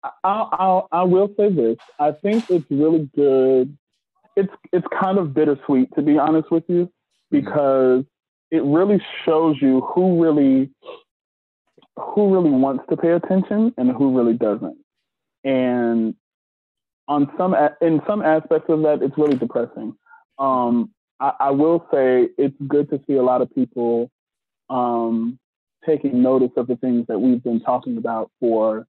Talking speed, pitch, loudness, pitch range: 150 wpm, 150 Hz, -19 LUFS, 130-180 Hz